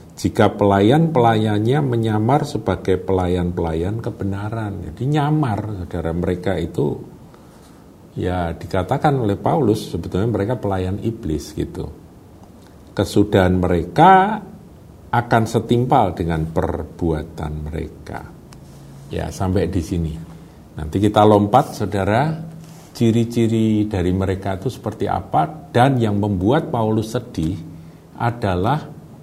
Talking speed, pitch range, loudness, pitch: 95 wpm, 90-120 Hz, -19 LUFS, 105 Hz